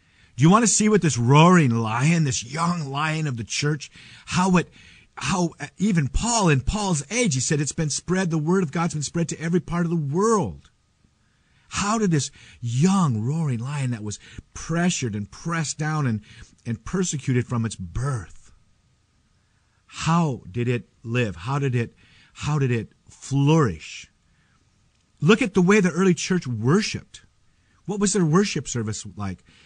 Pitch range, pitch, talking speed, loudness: 115-175 Hz, 150 Hz, 170 wpm, -22 LUFS